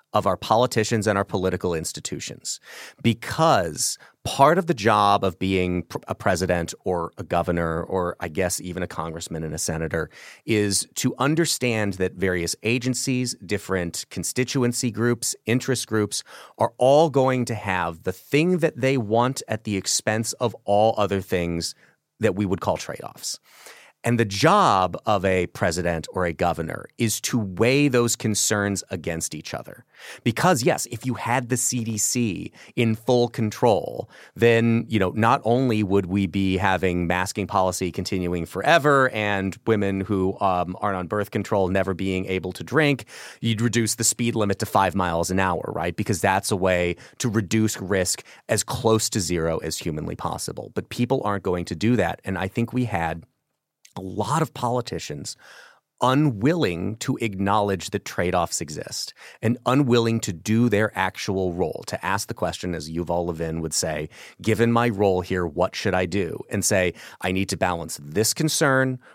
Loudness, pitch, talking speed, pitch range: -23 LUFS, 105 Hz, 170 wpm, 95-120 Hz